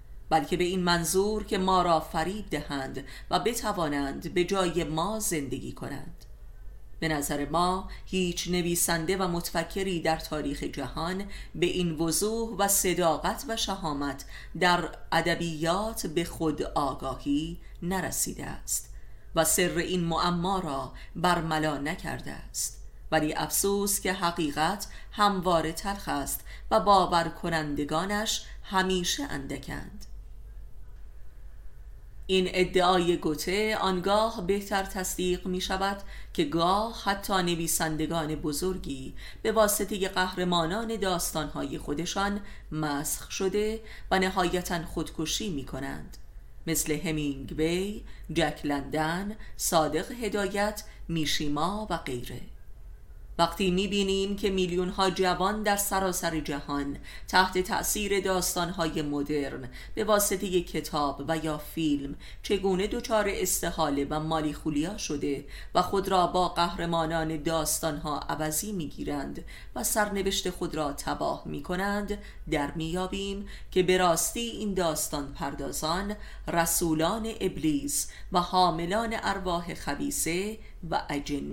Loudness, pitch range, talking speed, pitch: -29 LUFS, 155-195 Hz, 115 wpm, 175 Hz